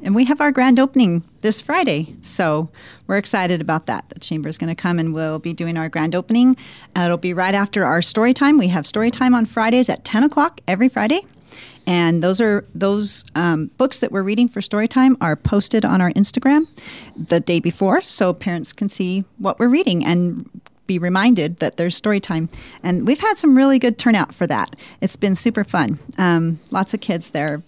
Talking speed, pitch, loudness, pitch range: 210 wpm, 195 Hz, -18 LUFS, 170-245 Hz